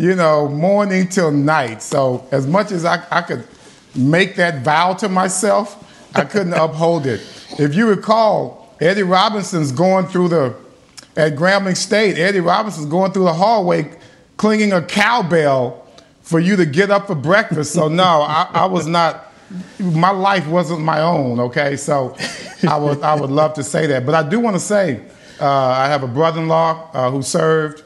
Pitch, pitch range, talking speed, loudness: 170 Hz, 150-190 Hz, 180 wpm, -16 LUFS